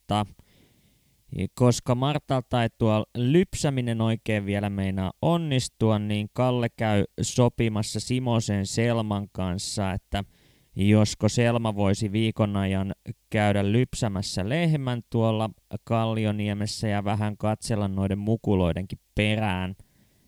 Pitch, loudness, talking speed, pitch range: 110 Hz, -26 LUFS, 100 wpm, 100-115 Hz